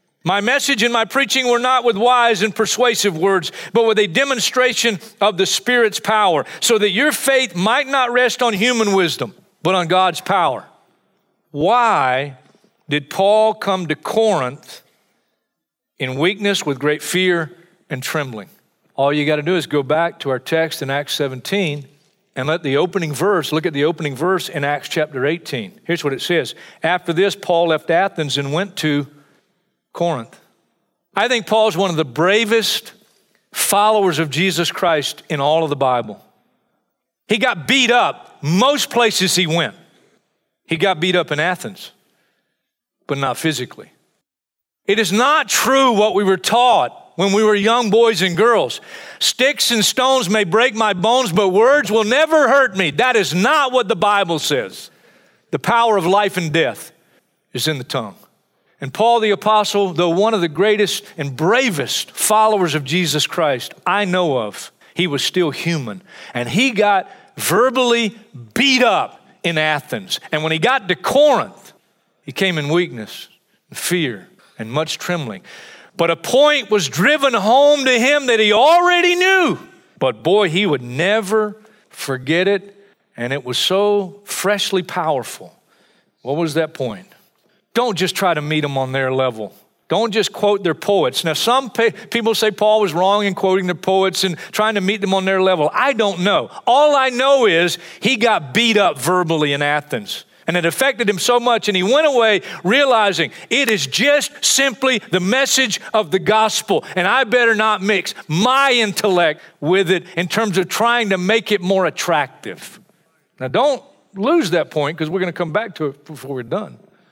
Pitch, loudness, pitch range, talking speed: 195 Hz, -16 LUFS, 165-225 Hz, 175 wpm